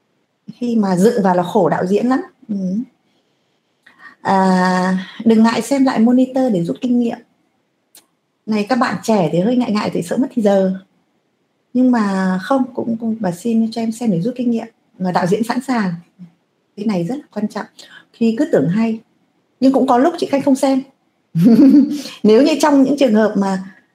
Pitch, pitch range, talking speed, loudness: 230 Hz, 195-255 Hz, 195 wpm, -16 LUFS